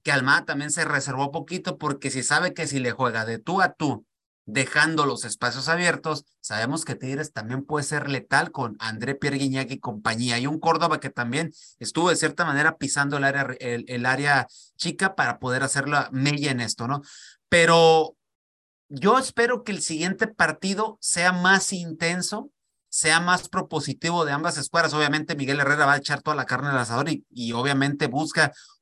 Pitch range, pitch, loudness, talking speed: 135-165 Hz, 145 Hz, -23 LUFS, 185 wpm